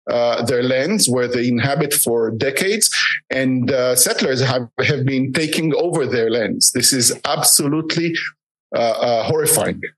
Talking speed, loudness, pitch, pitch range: 145 wpm, -16 LUFS, 130 Hz, 125-160 Hz